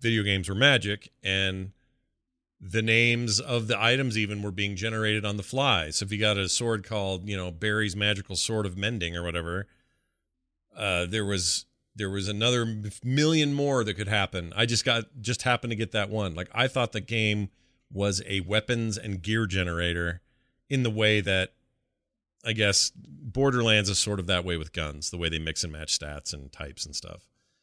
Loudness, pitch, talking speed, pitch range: -27 LUFS, 105 Hz, 195 wpm, 90-115 Hz